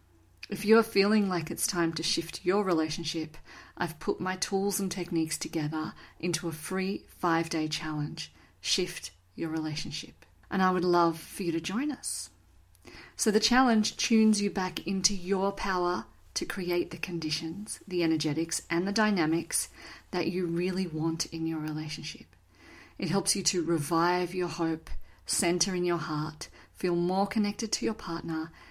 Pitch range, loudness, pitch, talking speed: 160-190 Hz, -30 LUFS, 170 Hz, 160 wpm